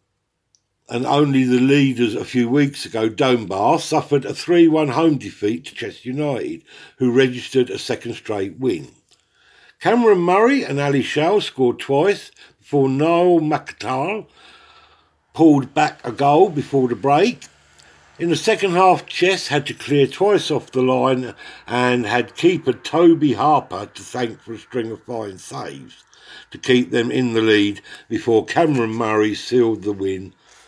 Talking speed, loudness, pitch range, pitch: 150 wpm, -18 LUFS, 120-155 Hz, 135 Hz